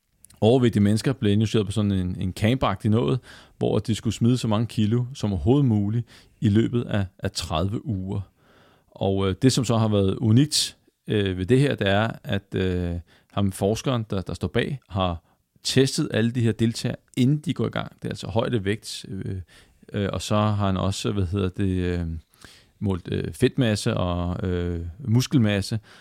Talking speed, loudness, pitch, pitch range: 185 wpm, -24 LUFS, 105 Hz, 95-120 Hz